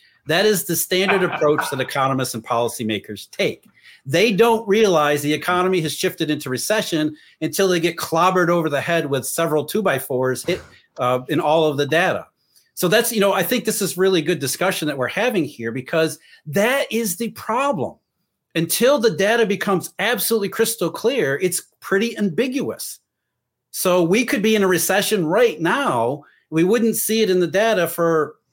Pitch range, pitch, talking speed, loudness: 155-210 Hz, 180 Hz, 180 wpm, -19 LUFS